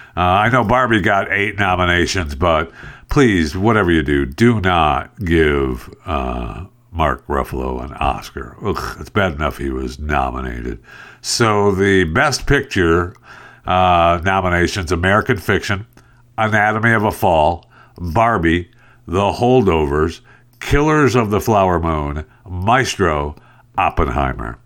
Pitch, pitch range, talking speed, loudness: 90 Hz, 75-110 Hz, 120 wpm, -16 LUFS